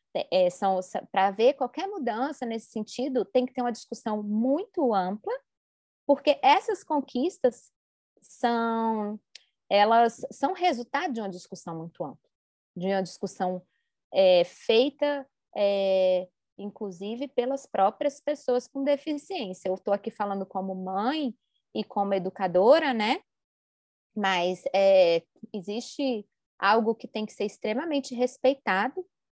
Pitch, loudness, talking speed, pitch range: 225 Hz, -27 LUFS, 120 wpm, 195-275 Hz